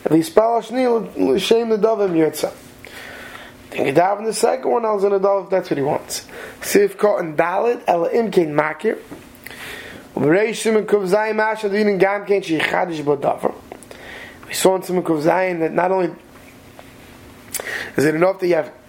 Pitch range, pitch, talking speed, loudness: 170-220 Hz, 195 Hz, 150 wpm, -18 LUFS